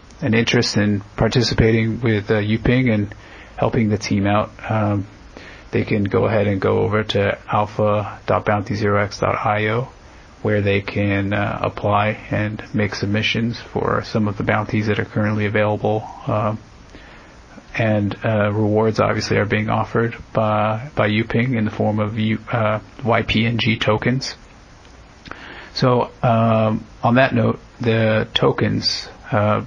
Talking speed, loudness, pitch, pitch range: 135 wpm, -19 LUFS, 110 Hz, 105-115 Hz